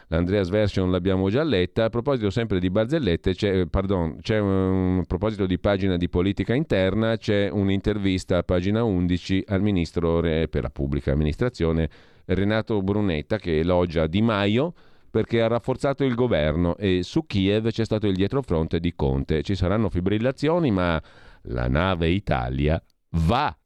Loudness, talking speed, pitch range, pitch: -23 LUFS, 150 wpm, 85-110 Hz, 95 Hz